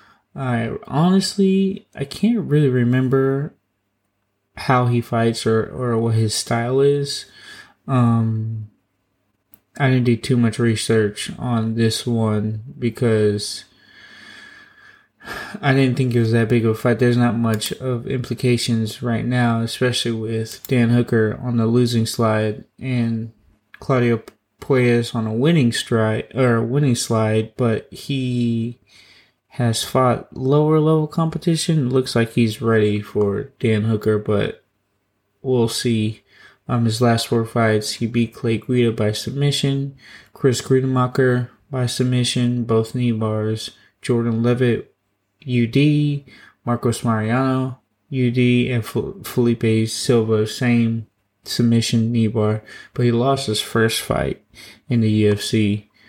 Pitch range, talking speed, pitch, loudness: 110-130 Hz, 130 wpm, 120 Hz, -19 LUFS